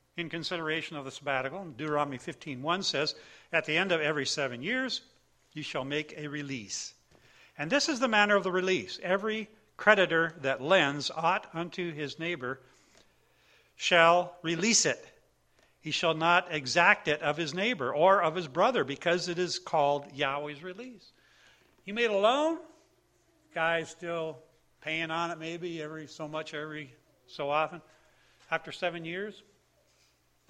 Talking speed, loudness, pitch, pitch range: 150 wpm, -29 LUFS, 165 Hz, 150-185 Hz